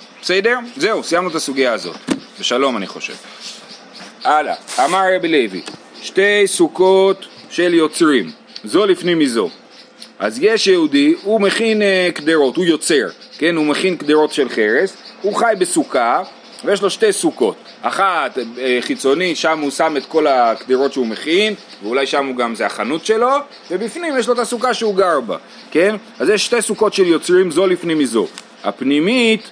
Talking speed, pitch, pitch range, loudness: 160 wpm, 190 Hz, 160-245 Hz, -16 LUFS